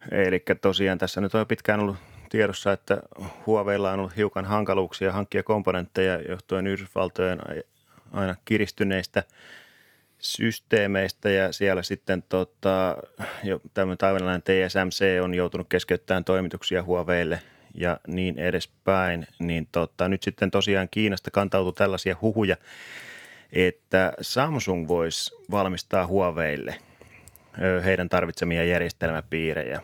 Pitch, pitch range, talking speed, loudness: 95 Hz, 90-100 Hz, 110 wpm, -25 LUFS